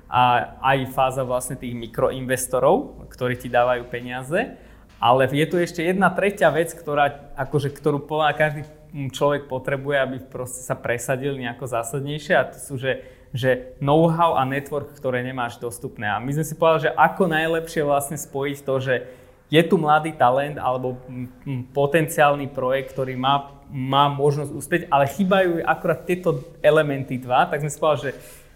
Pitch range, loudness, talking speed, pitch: 130-155 Hz, -22 LUFS, 160 wpm, 140 Hz